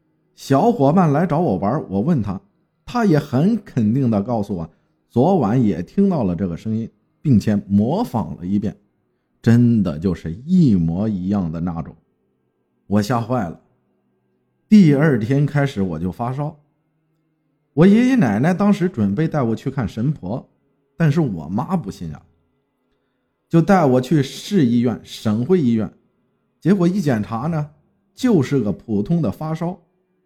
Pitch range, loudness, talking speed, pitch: 100-170 Hz, -18 LUFS, 210 characters per minute, 135 Hz